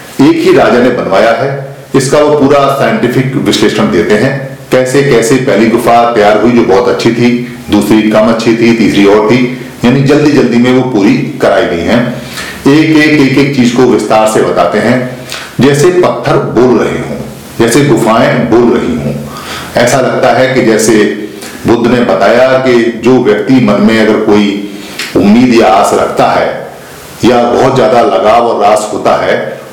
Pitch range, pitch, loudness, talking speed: 115-135 Hz, 125 Hz, -7 LUFS, 175 wpm